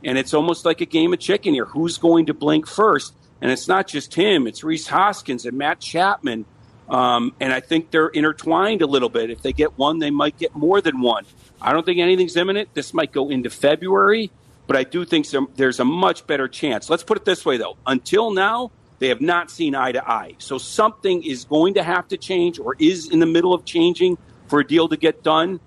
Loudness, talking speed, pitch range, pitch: -19 LUFS, 235 wpm, 140-195 Hz, 160 Hz